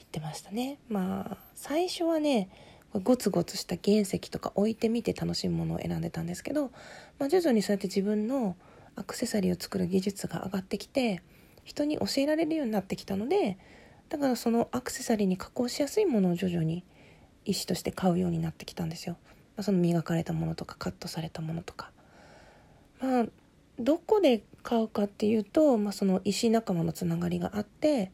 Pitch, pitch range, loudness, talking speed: 205 Hz, 175-245 Hz, -30 LUFS, 345 characters per minute